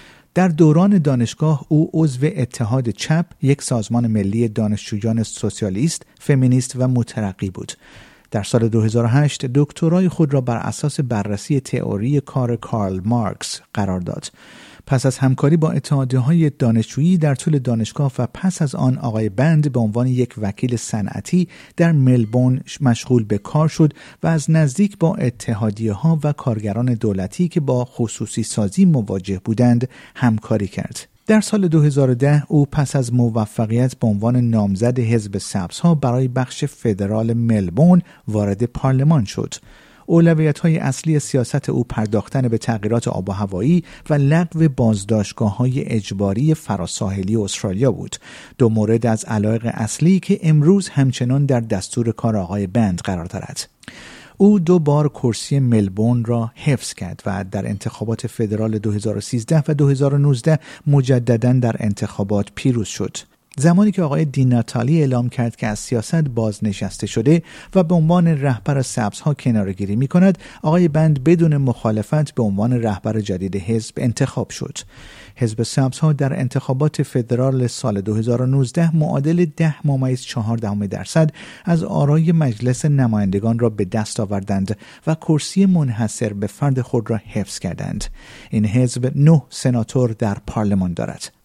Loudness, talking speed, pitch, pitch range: -18 LUFS, 140 wpm, 125 Hz, 110-150 Hz